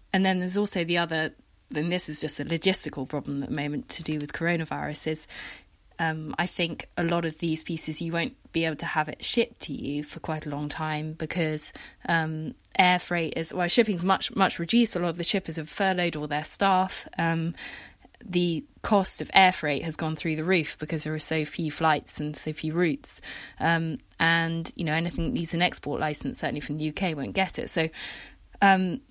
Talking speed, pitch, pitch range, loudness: 210 wpm, 165 Hz, 155-180 Hz, -27 LUFS